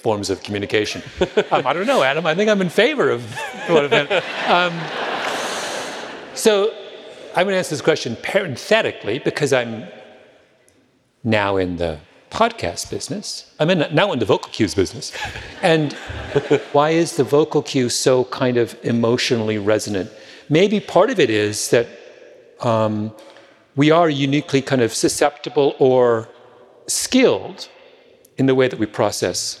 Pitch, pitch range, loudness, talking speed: 135 Hz, 110-170 Hz, -19 LUFS, 145 wpm